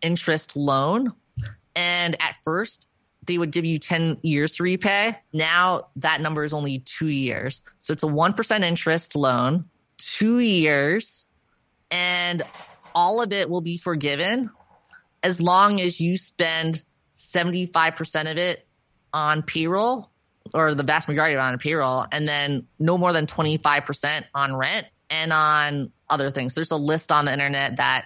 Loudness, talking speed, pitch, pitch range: -22 LUFS, 155 wpm, 160 Hz, 150-175 Hz